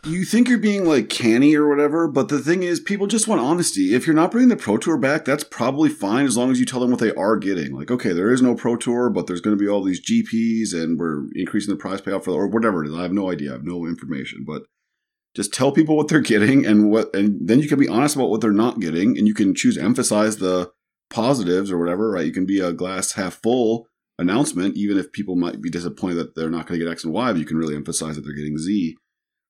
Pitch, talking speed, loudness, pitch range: 110 Hz, 275 wpm, -20 LUFS, 90-150 Hz